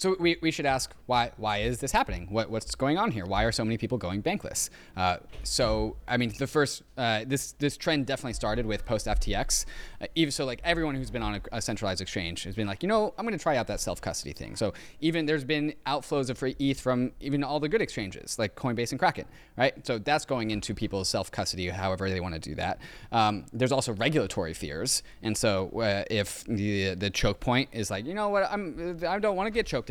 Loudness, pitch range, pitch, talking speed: -29 LUFS, 105-150 Hz, 125 Hz, 240 wpm